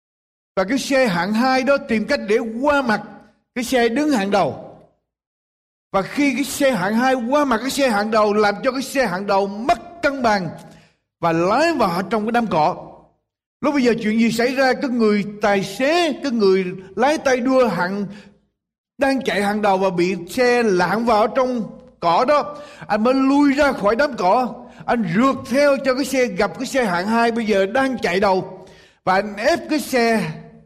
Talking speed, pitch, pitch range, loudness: 200 wpm, 230 Hz, 200-265 Hz, -19 LUFS